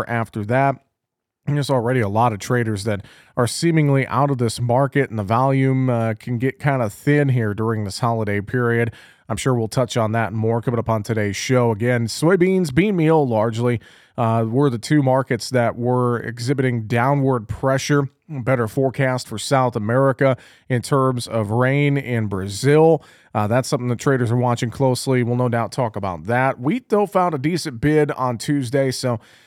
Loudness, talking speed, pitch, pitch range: -20 LUFS, 185 wpm, 125 Hz, 115-135 Hz